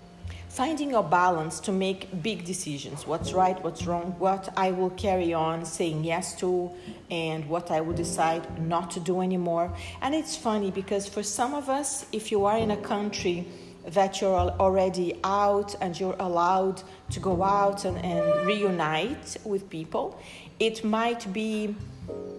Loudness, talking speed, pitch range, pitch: -28 LUFS, 160 wpm, 170-205 Hz, 190 Hz